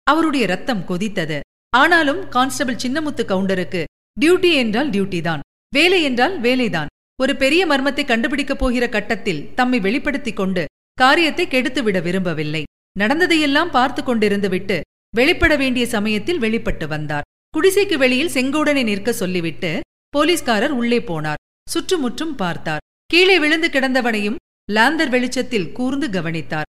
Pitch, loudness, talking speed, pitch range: 250 Hz, -18 LUFS, 115 wpm, 190-290 Hz